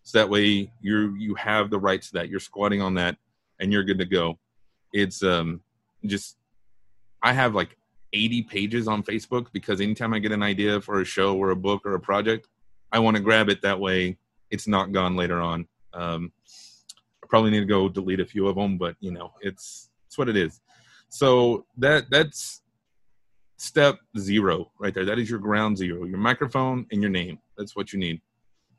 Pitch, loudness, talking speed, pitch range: 100 Hz, -24 LUFS, 200 wpm, 95-110 Hz